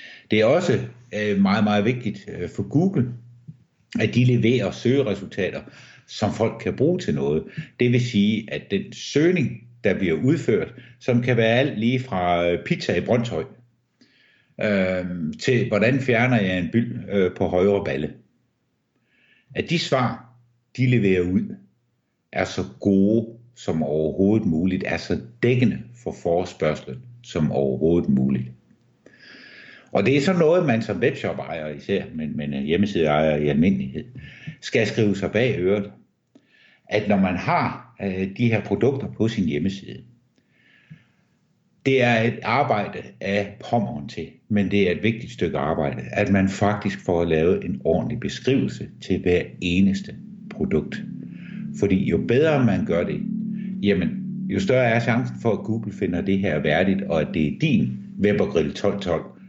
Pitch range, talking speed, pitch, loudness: 90-120 Hz, 145 wpm, 105 Hz, -22 LUFS